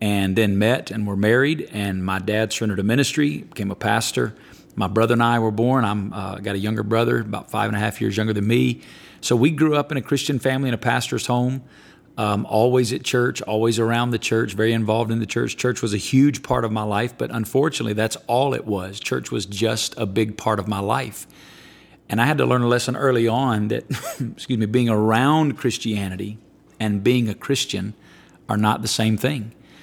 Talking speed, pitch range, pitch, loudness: 215 wpm, 105-125 Hz, 115 Hz, -21 LUFS